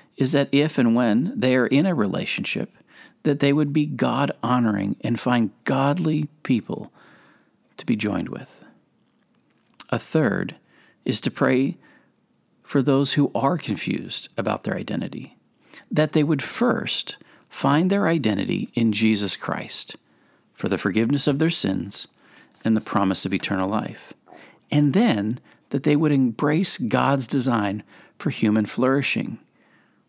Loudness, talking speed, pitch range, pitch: -22 LUFS, 140 wpm, 110-145 Hz, 135 Hz